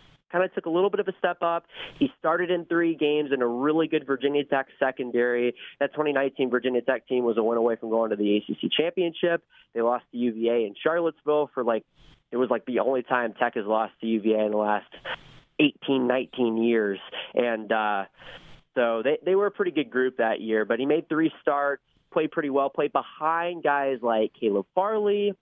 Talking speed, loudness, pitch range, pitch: 210 wpm, -26 LUFS, 115-160 Hz, 135 Hz